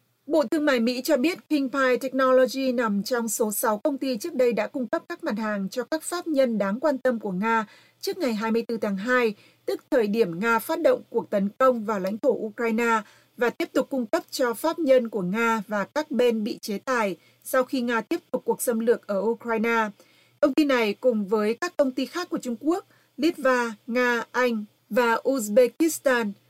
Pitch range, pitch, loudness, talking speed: 225-280 Hz, 245 Hz, -25 LUFS, 210 wpm